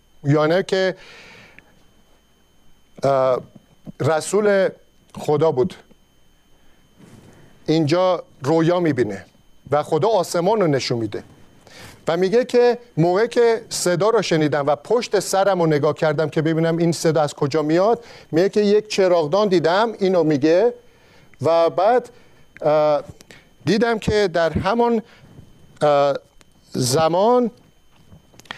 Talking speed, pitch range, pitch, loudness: 105 wpm, 155-205 Hz, 170 Hz, -19 LUFS